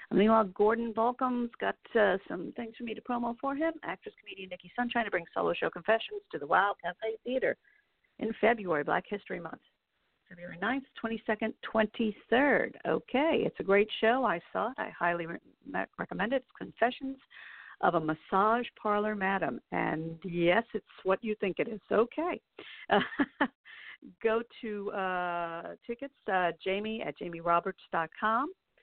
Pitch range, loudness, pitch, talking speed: 185-240 Hz, -31 LUFS, 220 Hz, 160 wpm